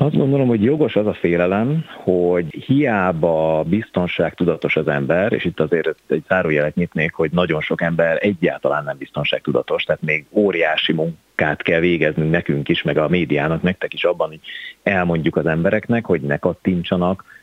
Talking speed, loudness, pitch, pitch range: 160 wpm, -19 LUFS, 90 Hz, 80-105 Hz